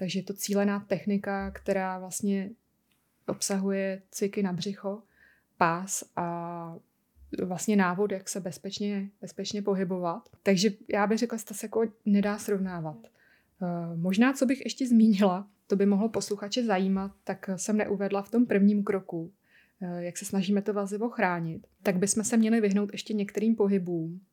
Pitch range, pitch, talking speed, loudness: 190-210 Hz, 200 Hz, 150 wpm, -29 LUFS